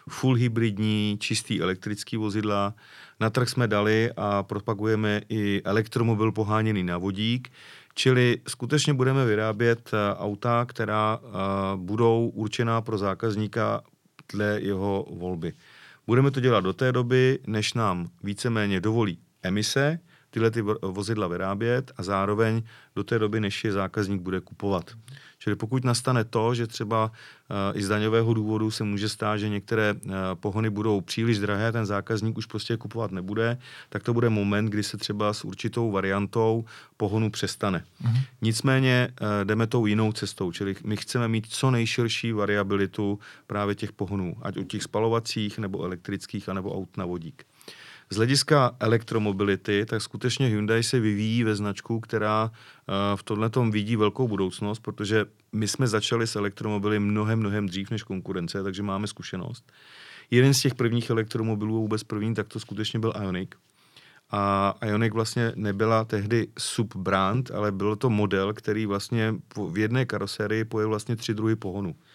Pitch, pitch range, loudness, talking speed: 110 Hz, 100-115 Hz, -26 LUFS, 150 wpm